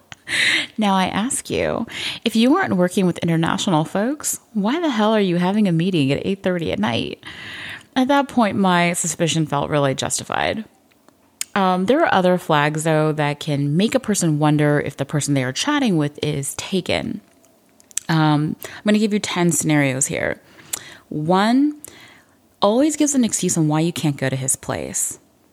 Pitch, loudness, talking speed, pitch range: 175 Hz, -19 LUFS, 175 wpm, 150-210 Hz